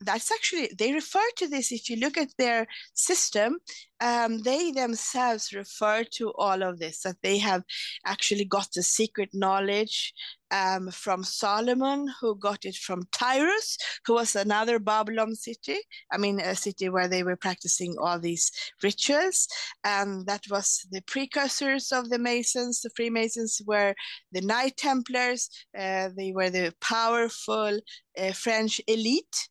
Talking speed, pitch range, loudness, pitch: 150 wpm, 195-260 Hz, -27 LUFS, 225 Hz